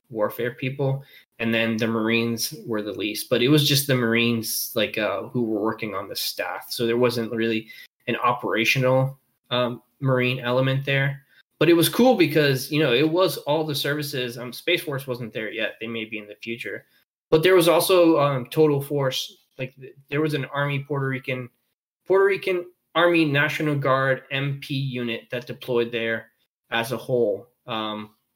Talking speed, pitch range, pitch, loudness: 180 wpm, 115-145 Hz, 130 Hz, -23 LUFS